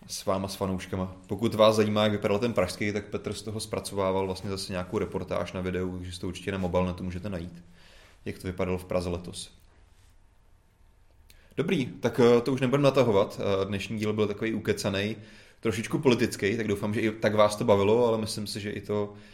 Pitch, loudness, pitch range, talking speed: 100 Hz, -28 LUFS, 90-110 Hz, 195 wpm